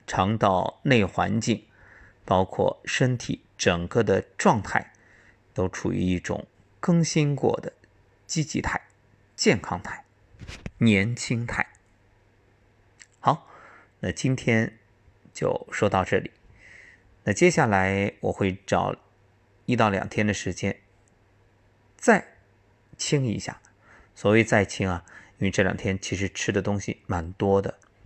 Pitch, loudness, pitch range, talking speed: 100 Hz, -25 LUFS, 95-115 Hz, 165 characters per minute